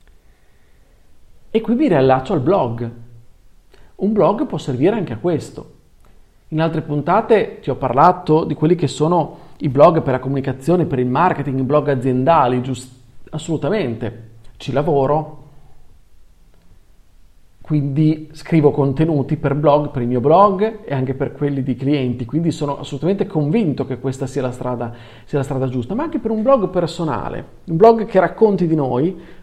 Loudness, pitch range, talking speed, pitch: -17 LUFS, 125-165 Hz, 160 wpm, 140 Hz